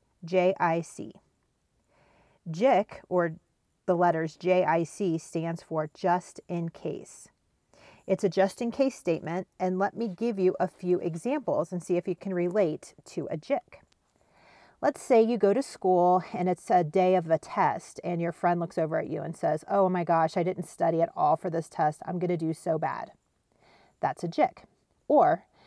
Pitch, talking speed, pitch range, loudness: 180 Hz, 180 wpm, 165-190 Hz, -28 LUFS